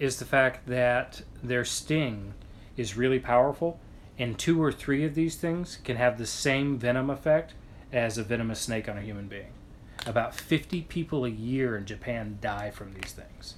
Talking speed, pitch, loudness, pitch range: 180 wpm, 125 Hz, -29 LUFS, 110-140 Hz